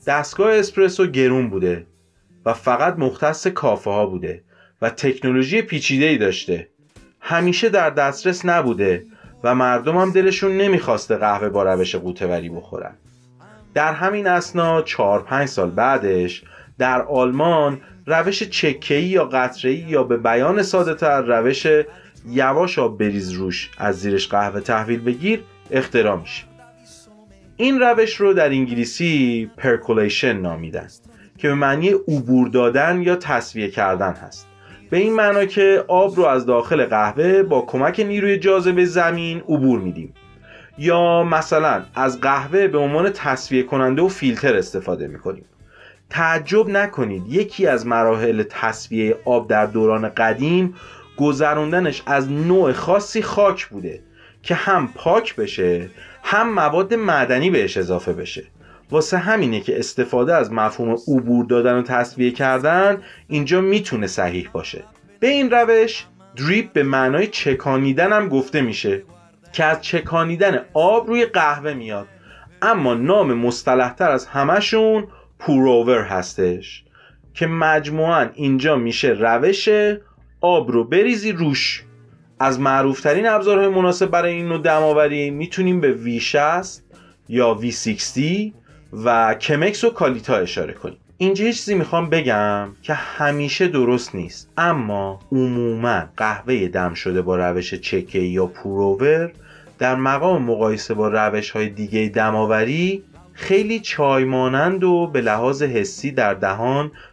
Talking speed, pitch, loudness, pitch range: 130 wpm, 140 Hz, -18 LUFS, 115-180 Hz